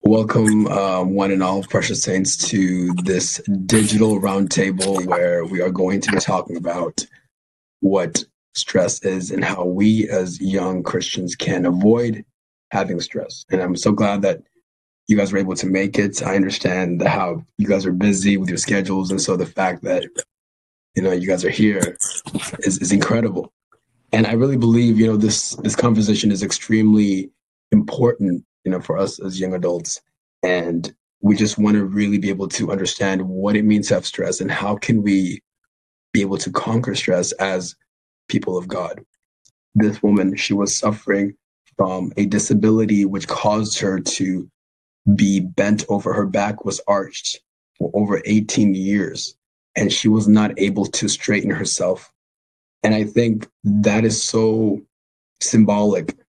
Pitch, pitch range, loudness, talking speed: 100 Hz, 95-105 Hz, -19 LUFS, 165 wpm